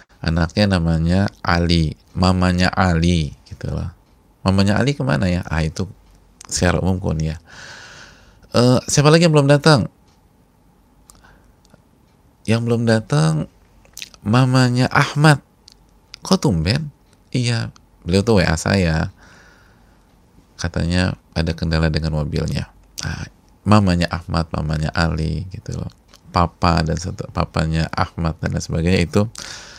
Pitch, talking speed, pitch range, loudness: 90 Hz, 110 wpm, 80-110 Hz, -18 LUFS